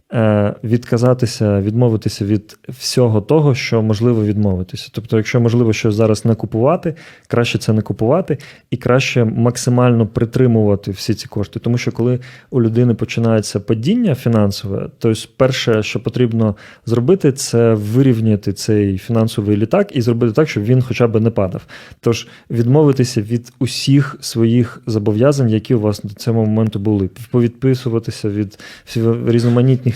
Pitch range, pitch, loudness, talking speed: 110-125 Hz, 115 Hz, -16 LUFS, 140 wpm